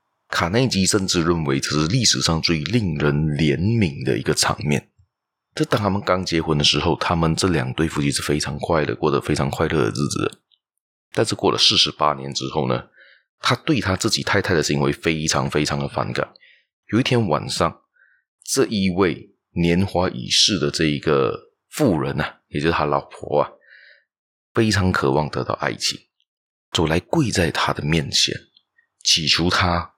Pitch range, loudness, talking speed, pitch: 75-95 Hz, -20 LUFS, 250 characters per minute, 80 Hz